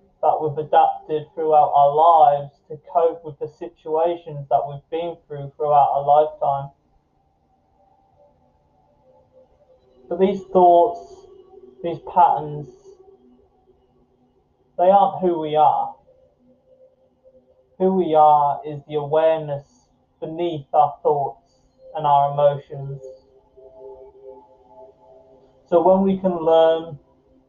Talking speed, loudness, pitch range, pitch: 100 wpm, -19 LUFS, 140-185 Hz, 155 Hz